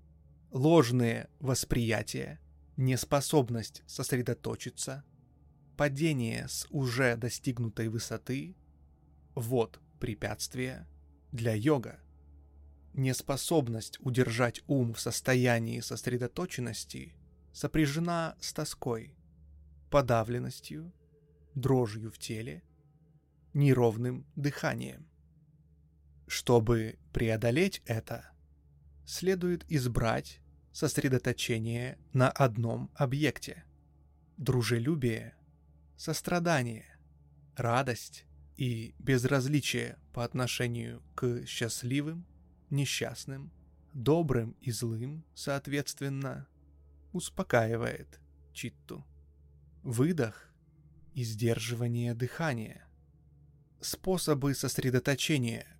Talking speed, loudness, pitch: 60 wpm, -32 LUFS, 120 Hz